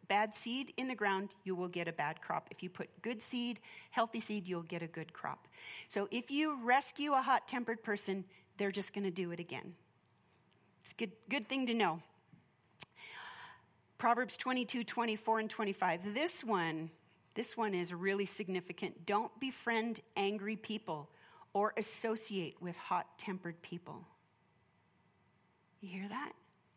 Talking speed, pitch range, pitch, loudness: 155 wpm, 185-235 Hz, 210 Hz, -38 LUFS